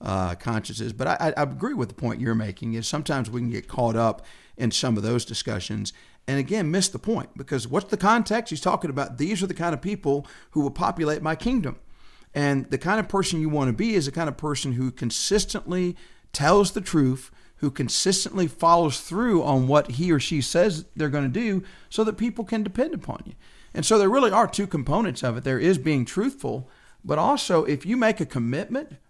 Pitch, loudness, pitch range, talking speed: 155 Hz, -24 LUFS, 130-195 Hz, 220 wpm